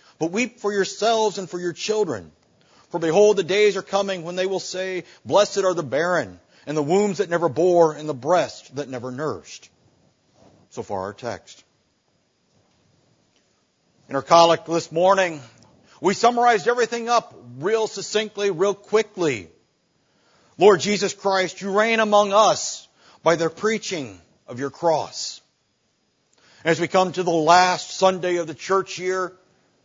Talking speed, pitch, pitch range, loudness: 150 wpm, 185 Hz, 165-205 Hz, -21 LUFS